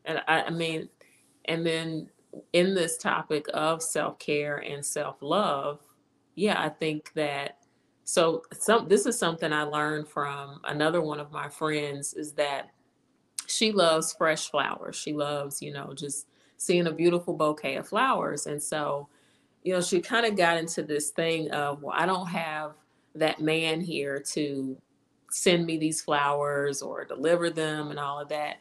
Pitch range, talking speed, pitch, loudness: 145-165 Hz, 165 wpm, 155 Hz, -28 LUFS